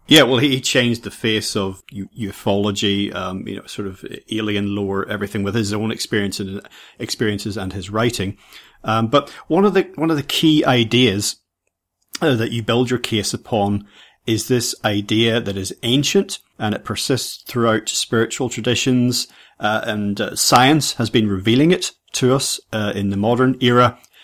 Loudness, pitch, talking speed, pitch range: -18 LUFS, 110 Hz, 175 wpm, 105-125 Hz